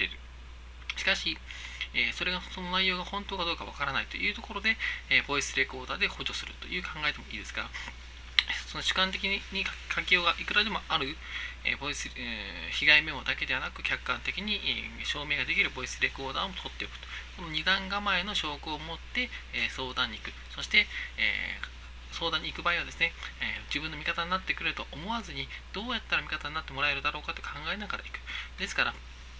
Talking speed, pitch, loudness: 390 characters per minute, 150 Hz, -30 LUFS